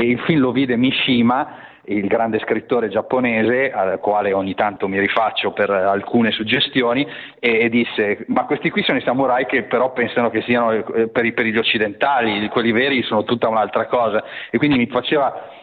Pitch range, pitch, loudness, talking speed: 110-130 Hz, 120 Hz, -18 LUFS, 175 wpm